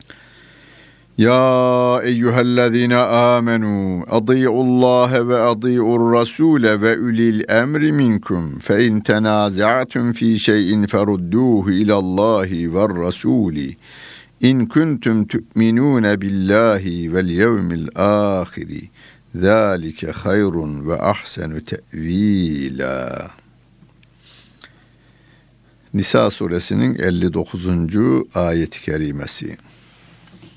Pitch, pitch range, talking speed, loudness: 105 Hz, 90-120 Hz, 65 wpm, -17 LUFS